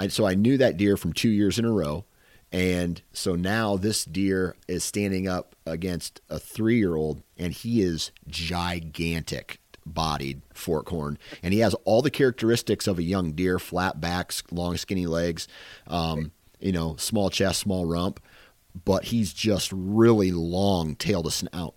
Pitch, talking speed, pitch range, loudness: 90 Hz, 170 wpm, 85-100 Hz, -26 LUFS